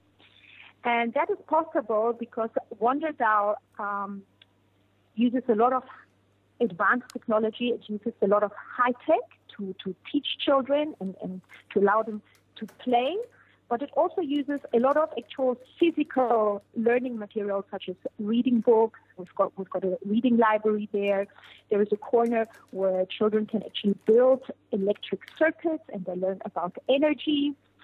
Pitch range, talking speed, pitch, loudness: 200-255 Hz, 150 wpm, 225 Hz, -27 LUFS